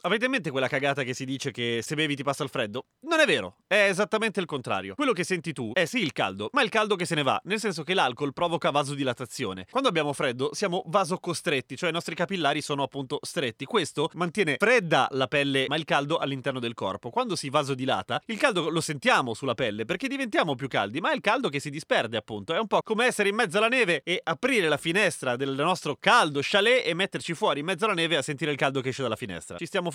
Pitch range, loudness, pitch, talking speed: 140-195 Hz, -26 LUFS, 160 Hz, 245 wpm